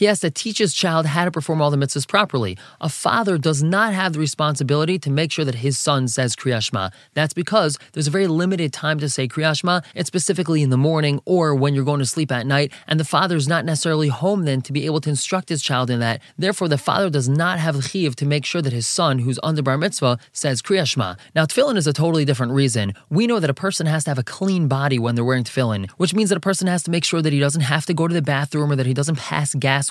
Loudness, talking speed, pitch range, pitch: -20 LUFS, 265 wpm, 135-170 Hz, 150 Hz